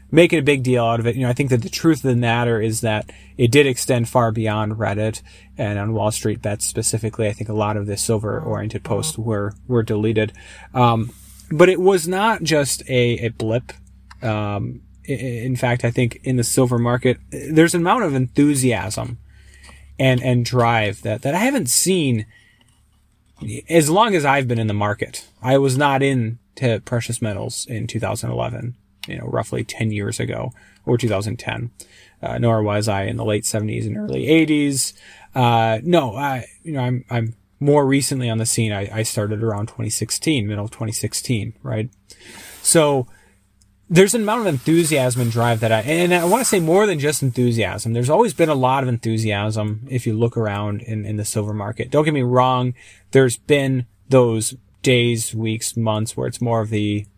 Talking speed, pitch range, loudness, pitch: 190 wpm, 105-130 Hz, -19 LUFS, 115 Hz